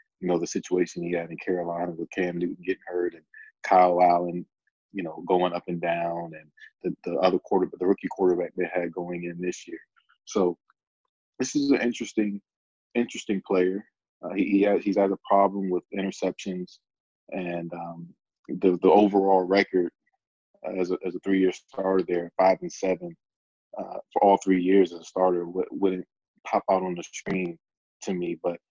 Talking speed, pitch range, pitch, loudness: 180 wpm, 85-100 Hz, 90 Hz, -26 LUFS